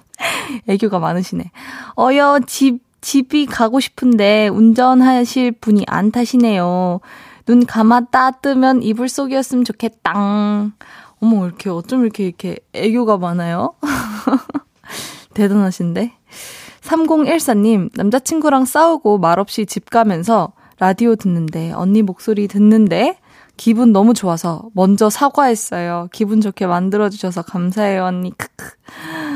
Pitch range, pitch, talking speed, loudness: 195-255 Hz, 220 Hz, 270 characters per minute, -15 LUFS